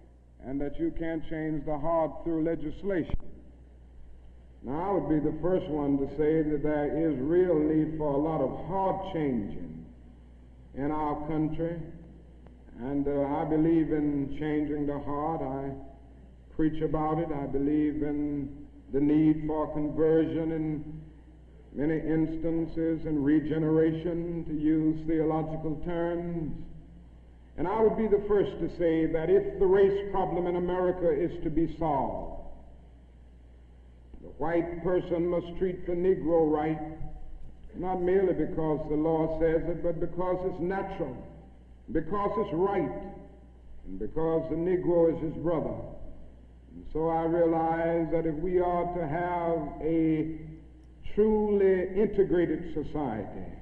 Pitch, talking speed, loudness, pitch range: 155 Hz, 140 wpm, -29 LUFS, 140-170 Hz